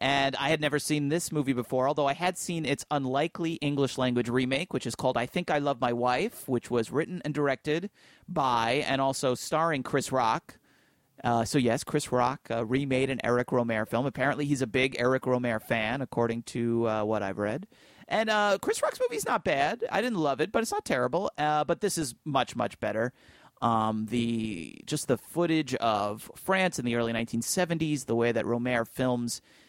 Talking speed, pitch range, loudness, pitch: 200 wpm, 120-150 Hz, -29 LUFS, 130 Hz